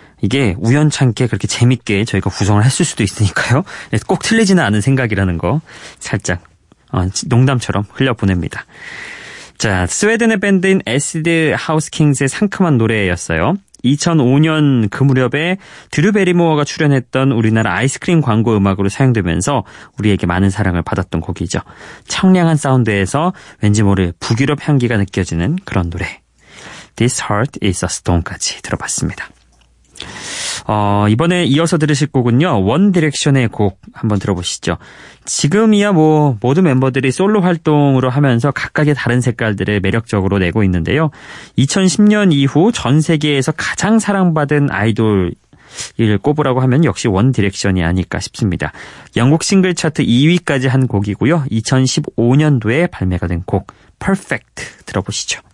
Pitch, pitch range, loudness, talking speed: 130 Hz, 100-155 Hz, -14 LUFS, 340 characters per minute